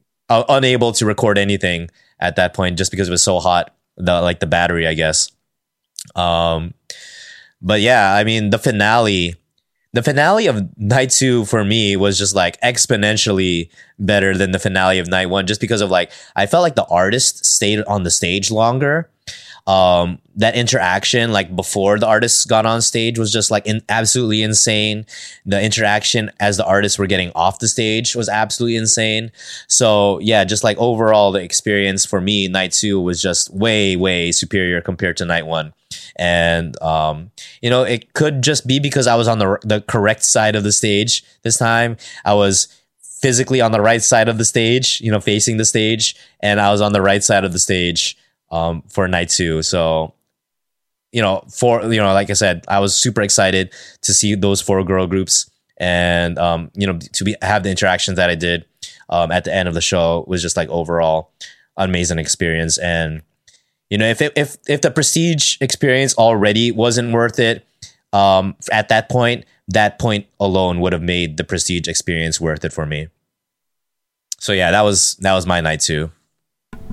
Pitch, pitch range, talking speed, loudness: 100 Hz, 90-115 Hz, 190 wpm, -15 LUFS